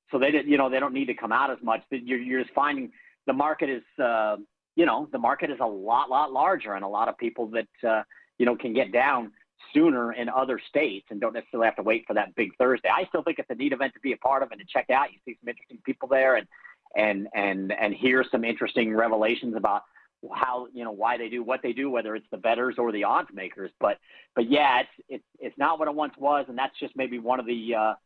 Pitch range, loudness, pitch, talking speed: 115-130 Hz, -26 LUFS, 120 Hz, 265 wpm